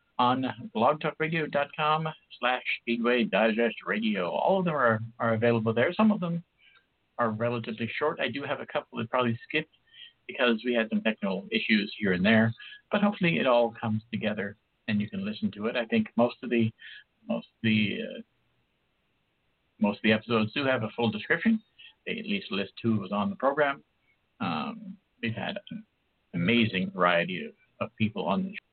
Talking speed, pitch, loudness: 185 wpm, 125 Hz, -28 LUFS